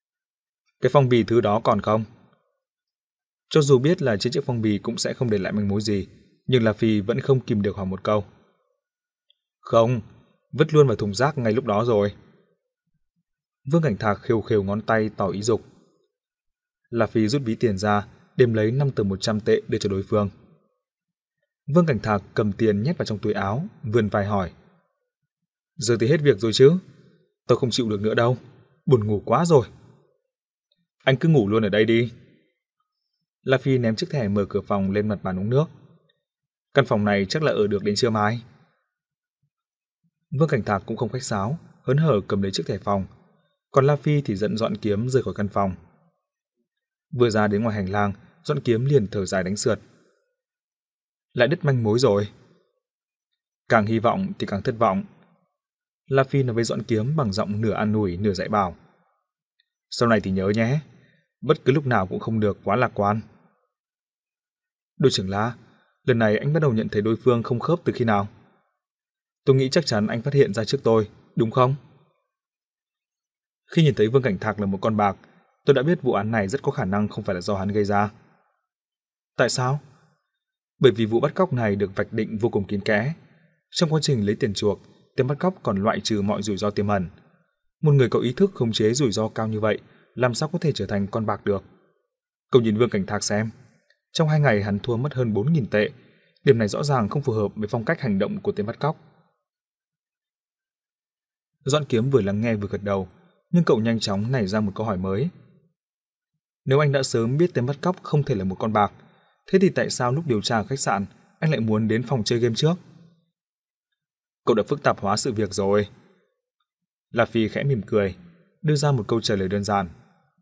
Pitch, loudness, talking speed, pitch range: 120 Hz, -23 LUFS, 210 wpm, 105-155 Hz